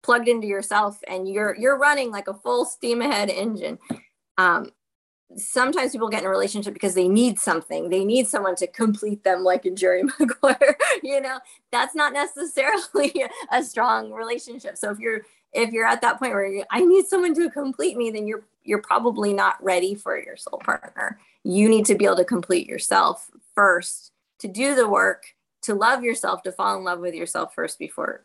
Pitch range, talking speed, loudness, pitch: 195-270 Hz, 195 wpm, -22 LUFS, 225 Hz